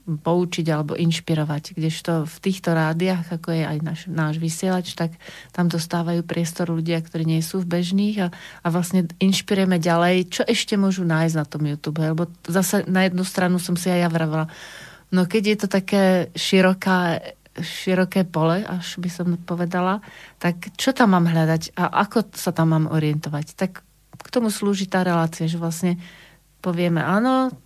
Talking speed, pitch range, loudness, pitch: 170 wpm, 165-185 Hz, -22 LUFS, 175 Hz